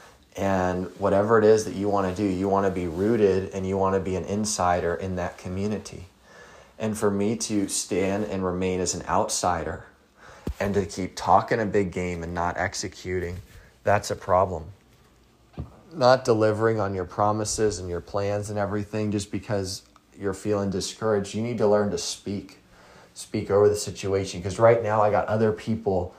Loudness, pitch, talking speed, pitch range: -25 LUFS, 100 Hz, 180 wpm, 90-105 Hz